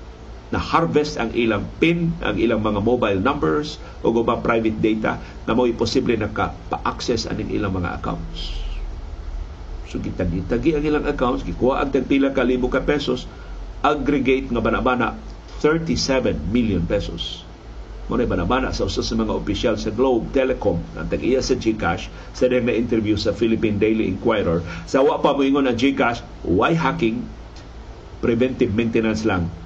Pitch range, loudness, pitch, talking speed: 95-130 Hz, -21 LUFS, 115 Hz, 145 wpm